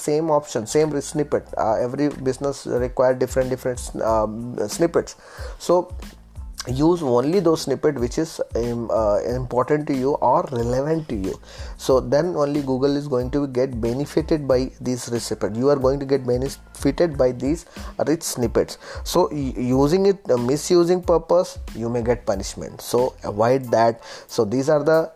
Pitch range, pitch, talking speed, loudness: 125-150 Hz, 135 Hz, 160 wpm, -21 LUFS